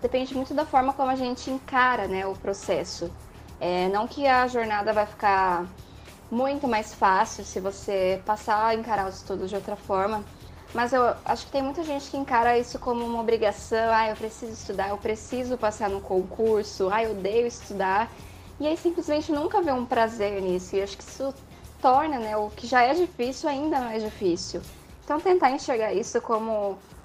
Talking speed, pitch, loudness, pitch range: 190 wpm, 225 Hz, -26 LUFS, 205-265 Hz